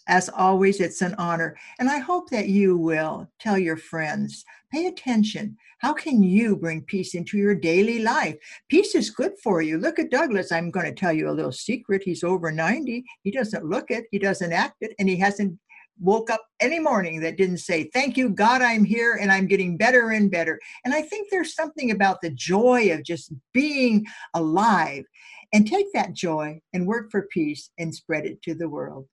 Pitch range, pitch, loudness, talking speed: 170-235 Hz, 195 Hz, -23 LUFS, 205 wpm